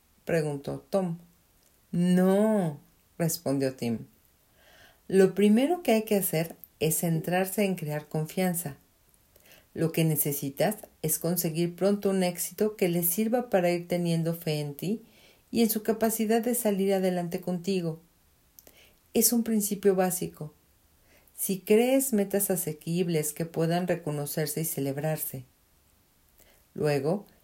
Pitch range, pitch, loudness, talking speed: 155-200 Hz, 175 Hz, -28 LUFS, 120 wpm